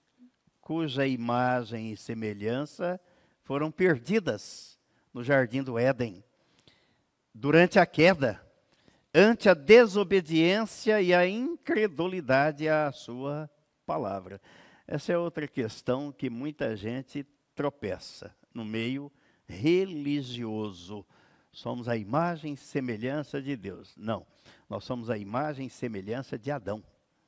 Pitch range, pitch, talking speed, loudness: 120-165 Hz, 140 Hz, 110 wpm, -28 LUFS